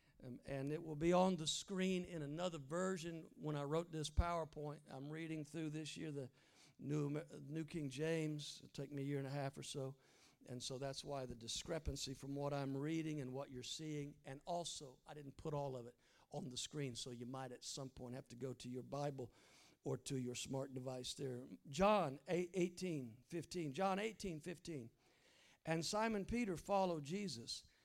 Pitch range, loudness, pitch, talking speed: 135-165 Hz, -45 LUFS, 145 Hz, 195 wpm